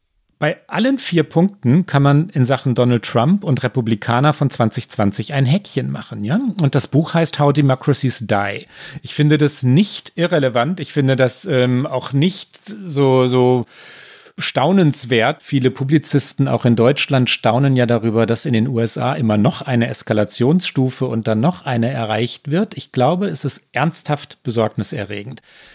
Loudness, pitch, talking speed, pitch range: -17 LUFS, 135 Hz, 155 wpm, 120-150 Hz